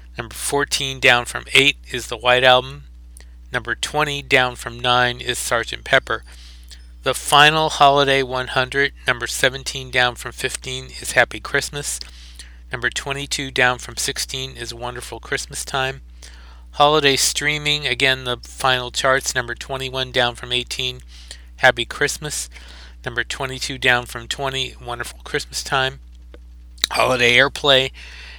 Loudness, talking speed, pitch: -19 LUFS, 130 wpm, 125 Hz